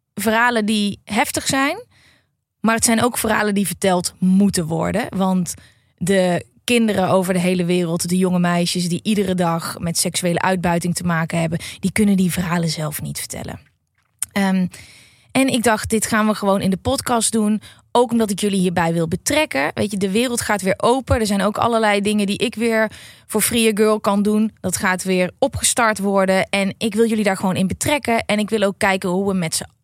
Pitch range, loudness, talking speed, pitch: 180-220 Hz, -18 LUFS, 205 wpm, 195 Hz